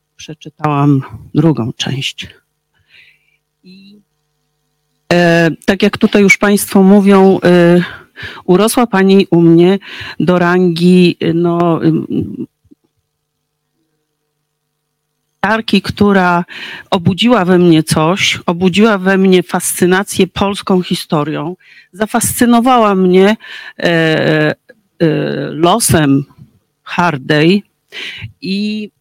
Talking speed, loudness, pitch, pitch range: 85 wpm, -11 LUFS, 175 Hz, 155-195 Hz